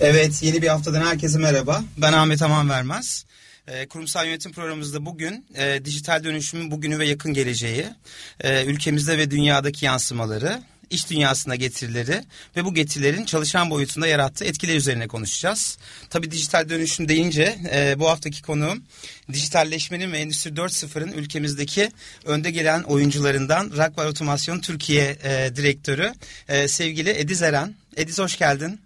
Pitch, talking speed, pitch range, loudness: 155 Hz, 135 wpm, 145-165 Hz, -22 LUFS